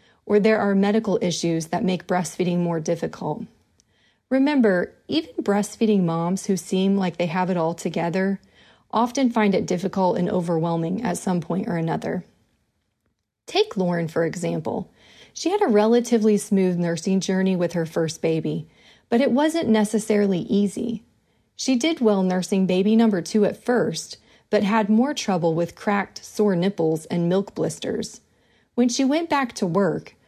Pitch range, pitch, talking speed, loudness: 175-220 Hz, 195 Hz, 155 wpm, -22 LUFS